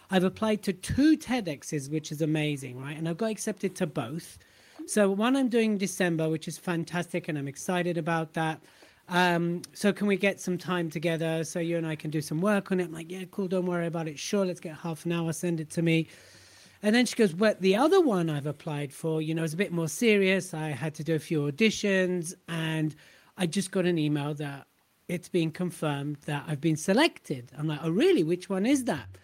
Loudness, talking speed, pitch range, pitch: -28 LUFS, 230 wpm, 160-195 Hz, 170 Hz